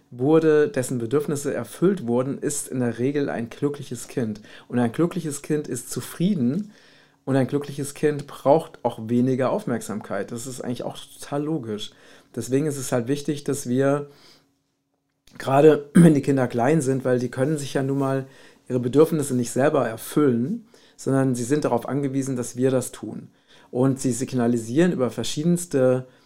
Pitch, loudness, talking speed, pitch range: 135 Hz, -23 LUFS, 160 wpm, 125-150 Hz